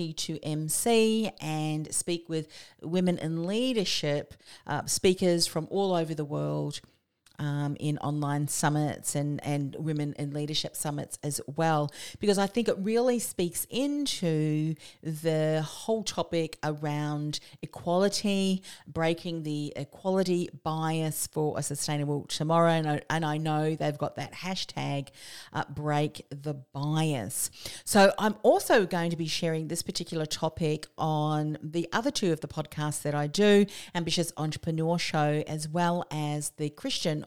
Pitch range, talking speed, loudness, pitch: 150-175 Hz, 140 wpm, -29 LUFS, 155 Hz